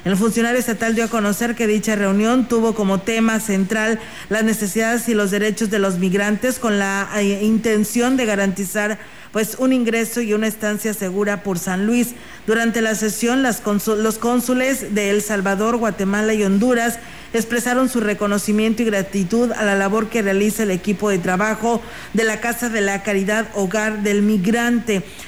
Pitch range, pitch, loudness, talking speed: 205-230 Hz, 215 Hz, -19 LUFS, 170 wpm